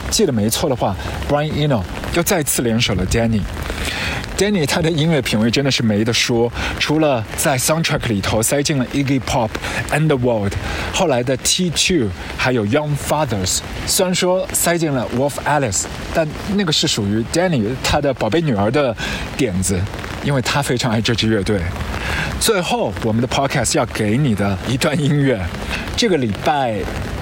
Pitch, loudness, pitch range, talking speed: 120 Hz, -18 LUFS, 100-150 Hz, 370 characters per minute